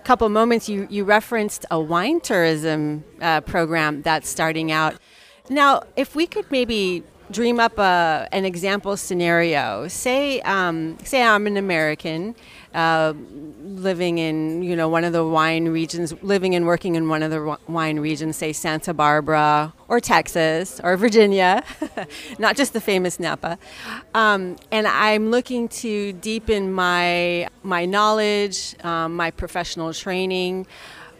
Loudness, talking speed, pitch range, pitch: -20 LUFS, 140 wpm, 160-215 Hz, 180 Hz